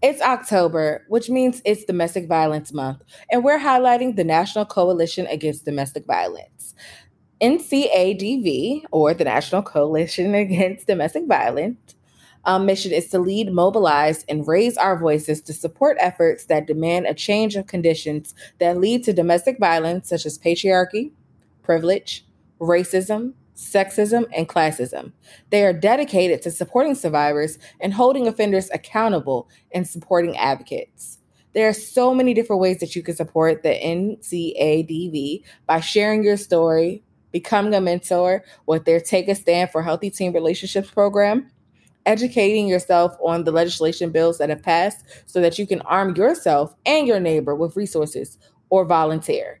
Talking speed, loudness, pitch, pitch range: 145 wpm, -20 LUFS, 180 Hz, 165-210 Hz